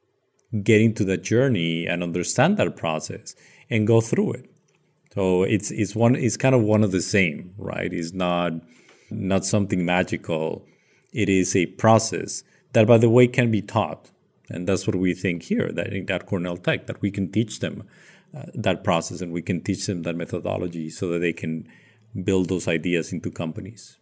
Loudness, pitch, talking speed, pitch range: -23 LUFS, 95 Hz, 185 wpm, 90-115 Hz